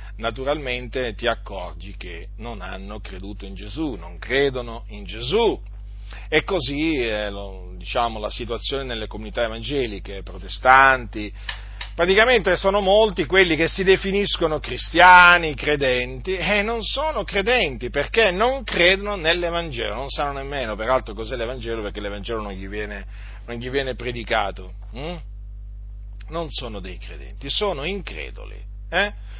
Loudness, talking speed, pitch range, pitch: -20 LUFS, 130 wpm, 100-165 Hz, 120 Hz